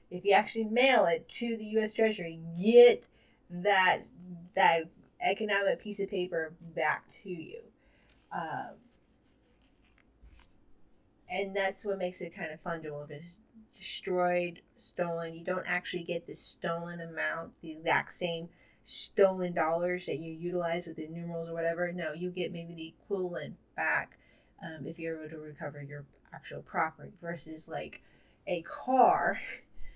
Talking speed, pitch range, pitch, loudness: 145 wpm, 165-195 Hz, 175 Hz, -31 LUFS